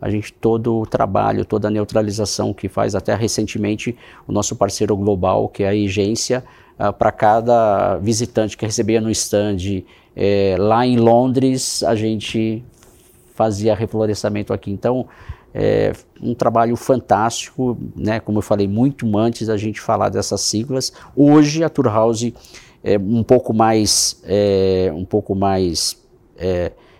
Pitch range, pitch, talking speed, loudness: 100-115 Hz, 110 Hz, 145 wpm, -18 LUFS